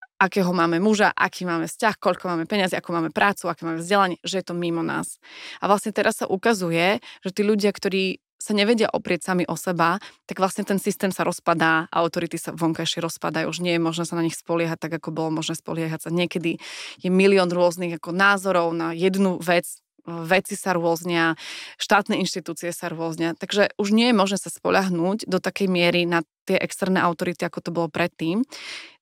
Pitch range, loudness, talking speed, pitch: 165-195 Hz, -23 LUFS, 190 wpm, 175 Hz